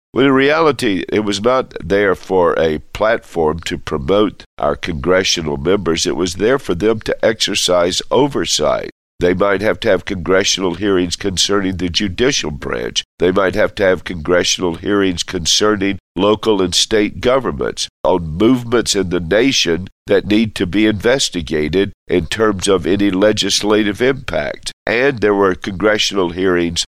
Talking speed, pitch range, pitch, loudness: 150 wpm, 90-105 Hz, 95 Hz, -15 LUFS